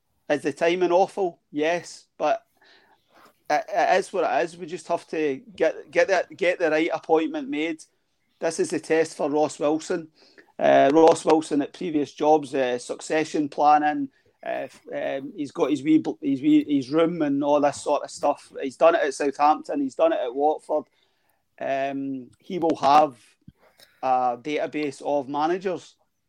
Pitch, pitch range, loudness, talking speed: 160 Hz, 150-185 Hz, -23 LUFS, 170 wpm